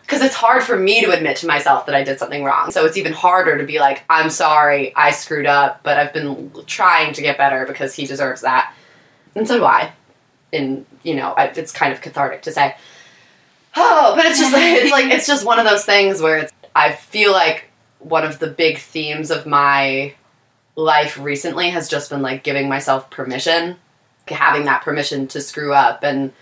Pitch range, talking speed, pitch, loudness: 140-175 Hz, 210 wpm, 150 Hz, -15 LUFS